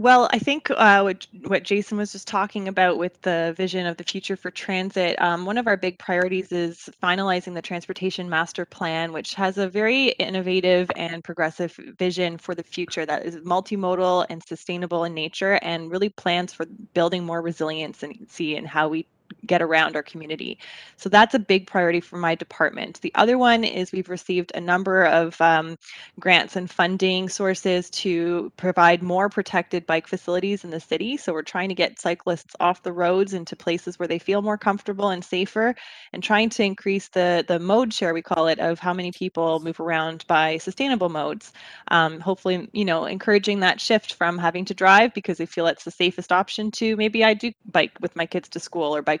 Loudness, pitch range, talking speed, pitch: -22 LUFS, 170-195 Hz, 200 wpm, 180 Hz